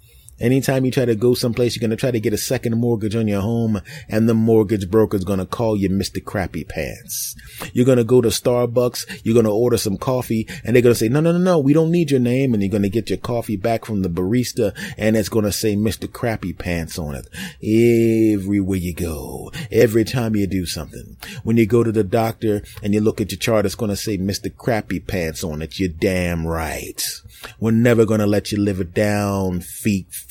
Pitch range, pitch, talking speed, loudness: 100-120 Hz, 110 Hz, 240 wpm, -19 LUFS